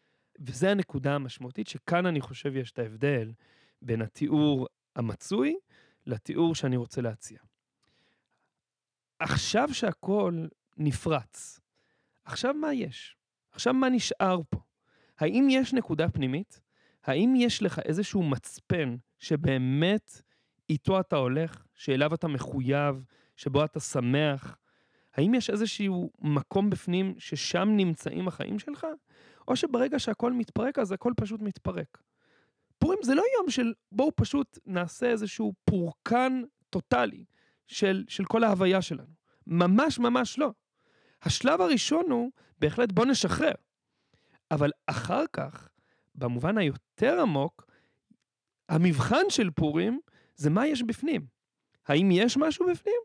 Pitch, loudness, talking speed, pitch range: 185 Hz, -28 LUFS, 120 wpm, 145-240 Hz